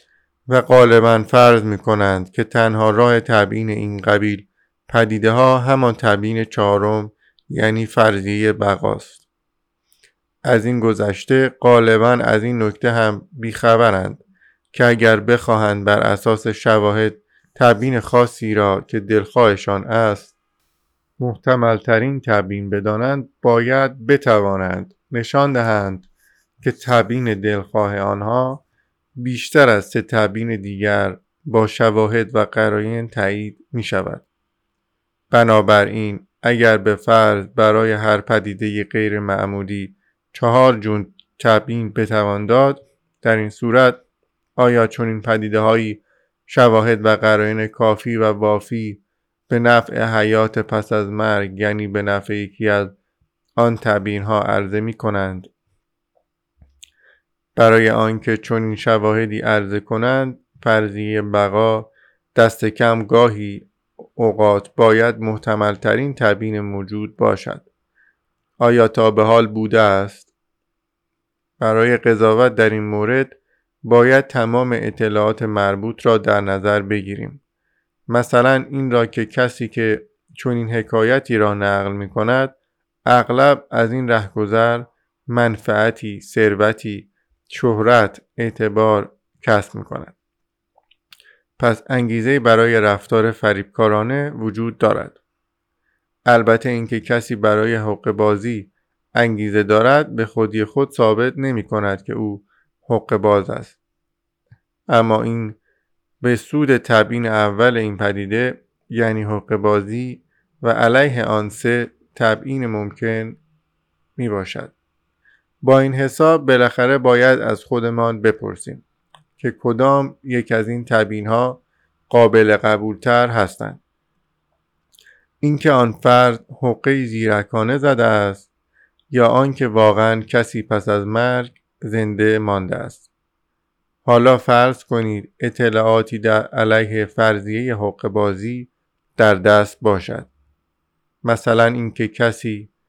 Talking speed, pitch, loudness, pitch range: 110 wpm, 110 Hz, -16 LUFS, 105-120 Hz